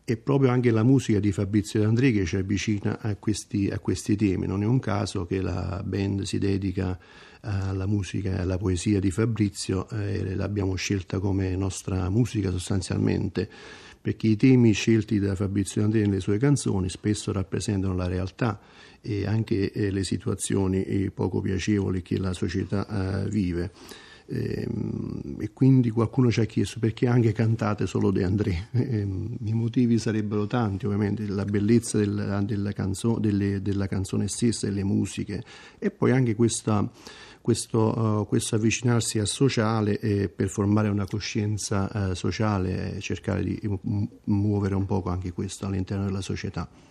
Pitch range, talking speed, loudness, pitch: 95-110 Hz, 160 wpm, -26 LUFS, 105 Hz